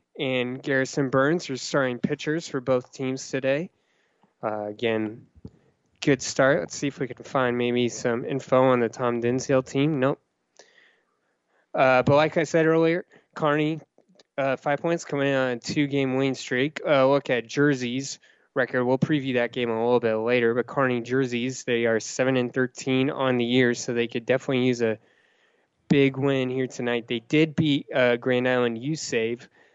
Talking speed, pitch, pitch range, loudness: 180 wpm, 130 Hz, 120-140 Hz, -24 LUFS